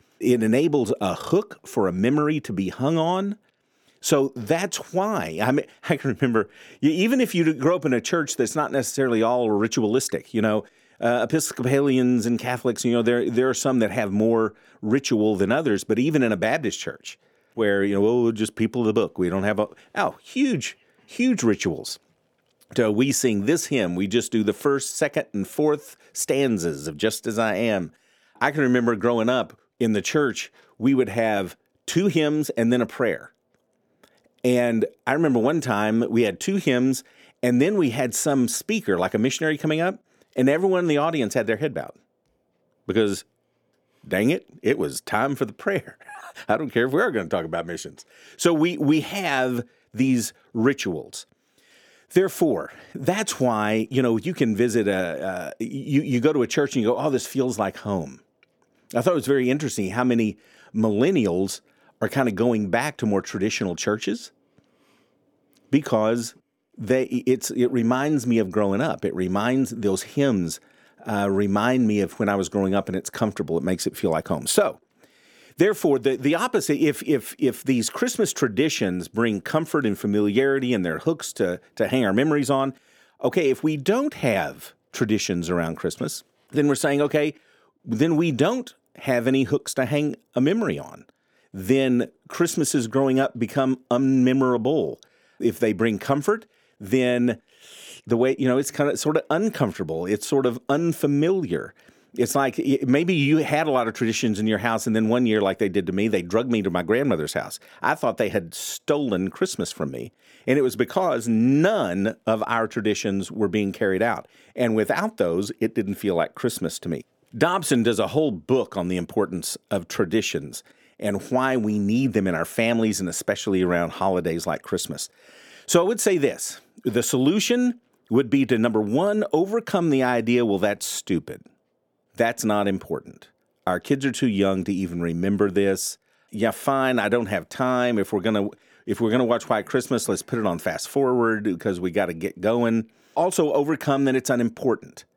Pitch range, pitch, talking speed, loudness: 110-140 Hz, 125 Hz, 190 wpm, -23 LUFS